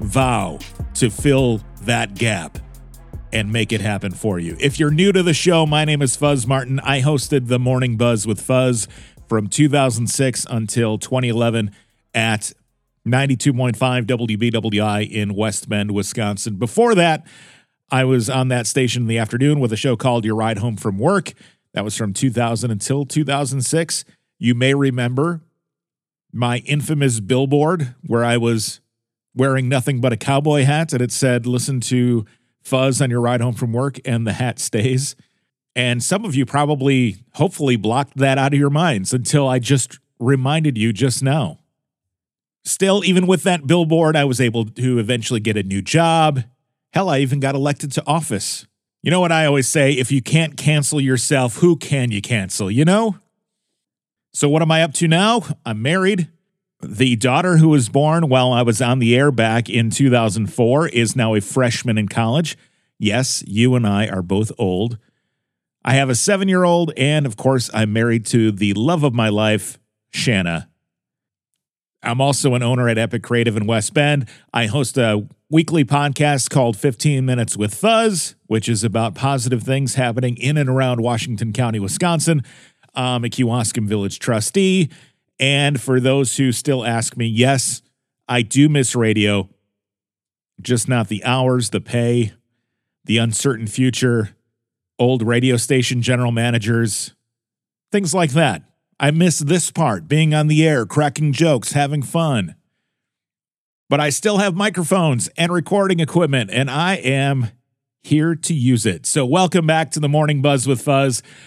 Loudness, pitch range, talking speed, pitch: -18 LUFS, 115-145 Hz, 165 wpm, 130 Hz